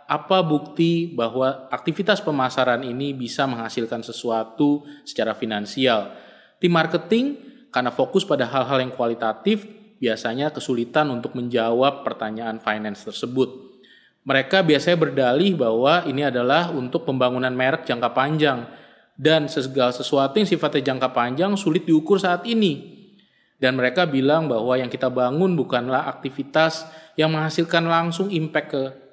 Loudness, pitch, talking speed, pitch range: -21 LUFS, 140 Hz, 130 wpm, 125-165 Hz